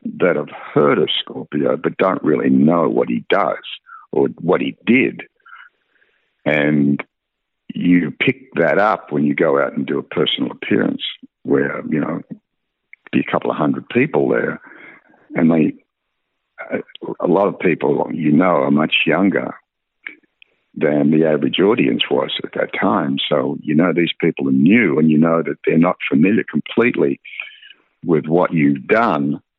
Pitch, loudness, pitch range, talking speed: 75 Hz, -17 LUFS, 70-85 Hz, 160 wpm